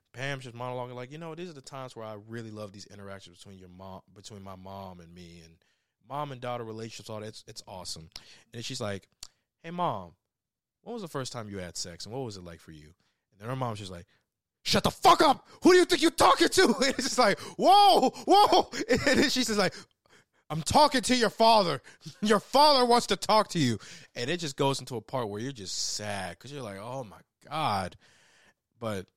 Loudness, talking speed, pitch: -26 LUFS, 230 wpm, 125 Hz